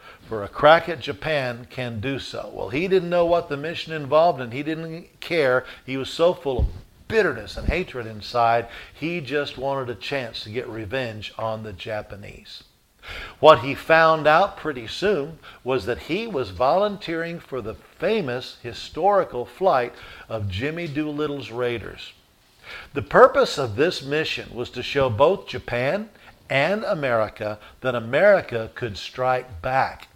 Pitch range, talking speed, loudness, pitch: 115-155 Hz, 150 wpm, -23 LUFS, 130 Hz